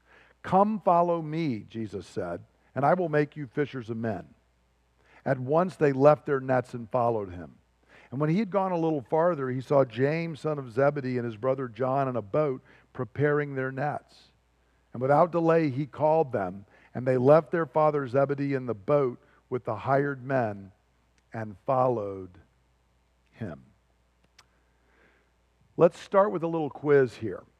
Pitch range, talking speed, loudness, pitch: 100-150 Hz, 165 wpm, -27 LUFS, 130 Hz